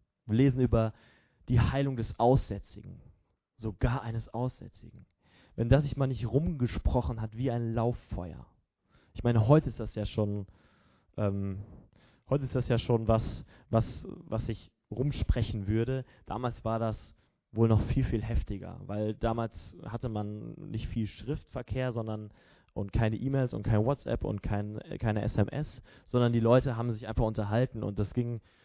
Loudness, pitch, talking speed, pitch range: -31 LUFS, 115 Hz, 155 wpm, 105-125 Hz